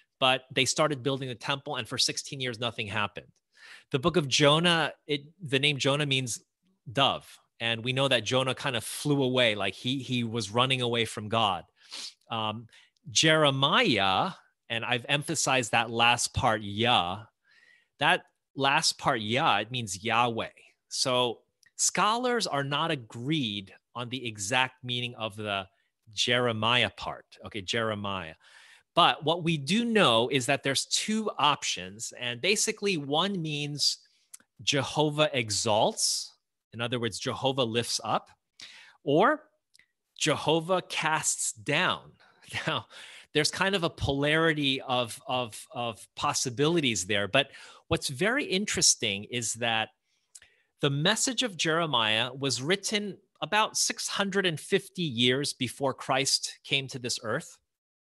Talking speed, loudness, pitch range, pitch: 130 wpm, -27 LUFS, 120-155 Hz, 135 Hz